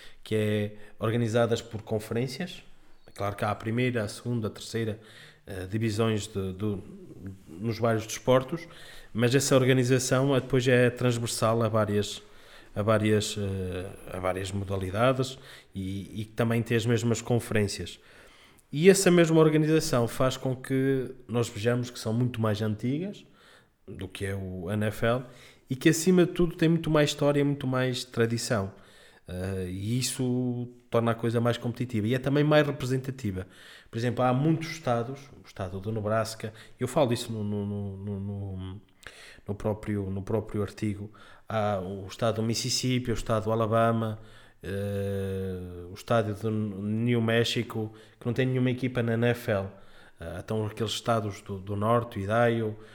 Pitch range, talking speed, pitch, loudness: 105-125 Hz, 155 wpm, 115 Hz, -28 LUFS